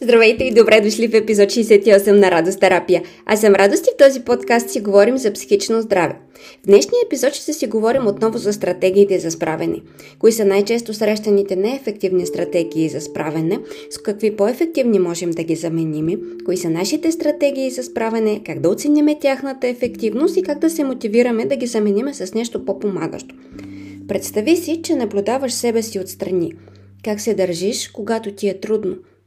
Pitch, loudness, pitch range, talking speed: 210 Hz, -17 LUFS, 185-245 Hz, 170 wpm